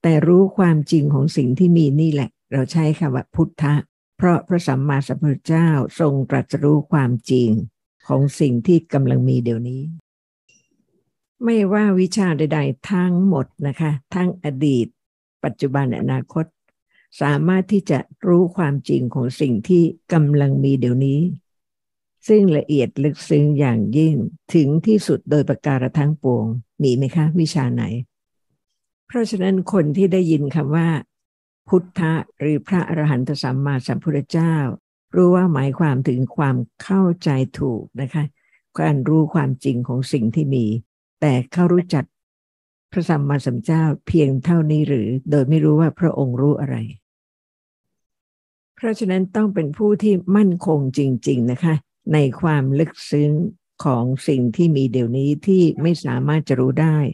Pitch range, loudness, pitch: 130-165 Hz, -19 LUFS, 150 Hz